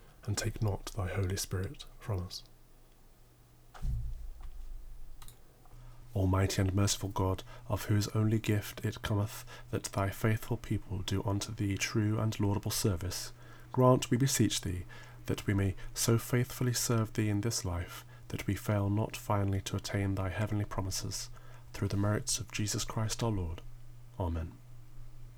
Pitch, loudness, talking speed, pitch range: 105 Hz, -34 LUFS, 145 wpm, 100-120 Hz